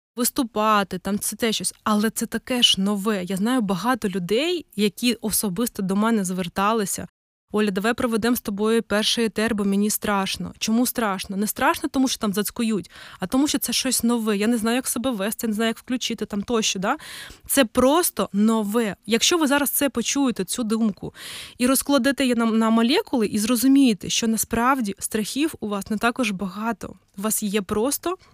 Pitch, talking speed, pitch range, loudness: 225 Hz, 180 wpm, 210-250 Hz, -22 LUFS